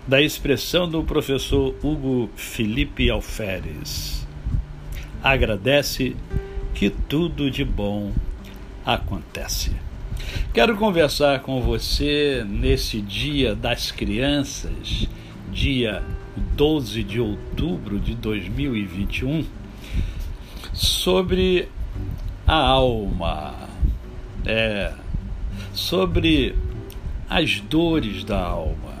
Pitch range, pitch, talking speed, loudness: 95-135 Hz, 110 Hz, 75 wpm, -23 LUFS